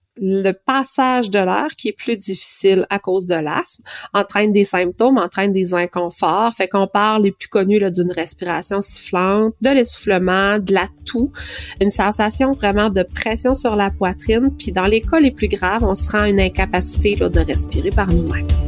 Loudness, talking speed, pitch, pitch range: -17 LUFS, 190 wpm, 200 Hz, 180-220 Hz